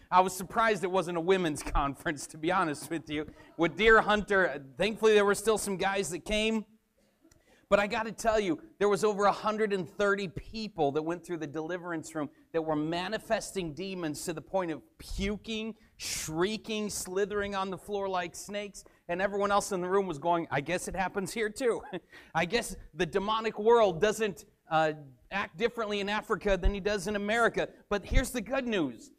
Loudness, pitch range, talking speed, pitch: -30 LUFS, 175-215 Hz, 190 wpm, 200 Hz